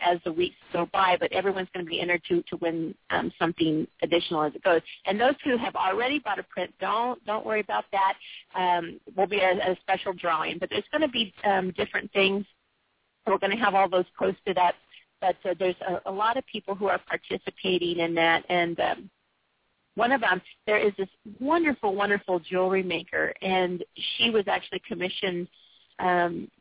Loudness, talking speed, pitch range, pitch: -27 LUFS, 195 wpm, 175-205 Hz, 190 Hz